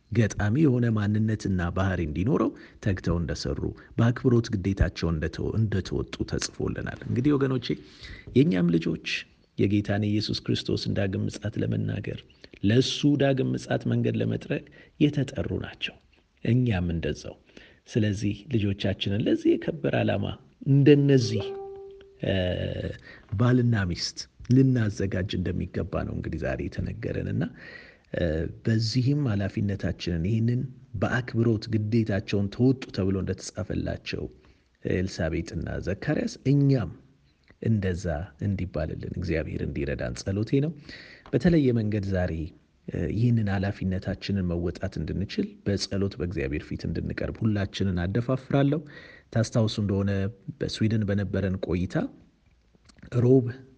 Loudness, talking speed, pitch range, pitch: -27 LUFS, 90 wpm, 90-120 Hz, 100 Hz